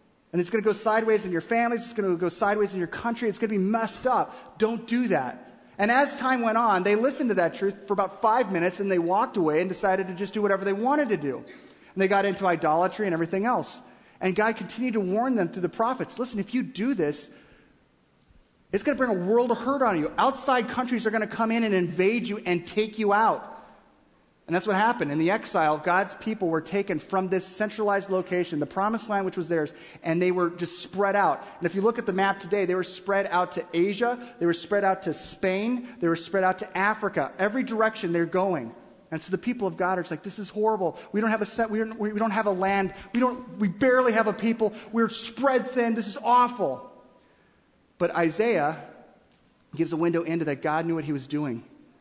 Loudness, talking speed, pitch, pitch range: -26 LUFS, 235 wpm, 200 Hz, 180-225 Hz